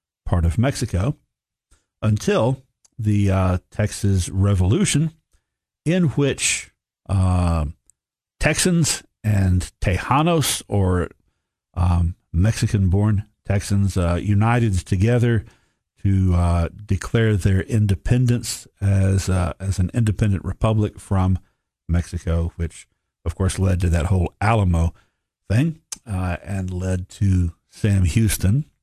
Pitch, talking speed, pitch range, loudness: 100 Hz, 100 wpm, 90-115 Hz, -21 LUFS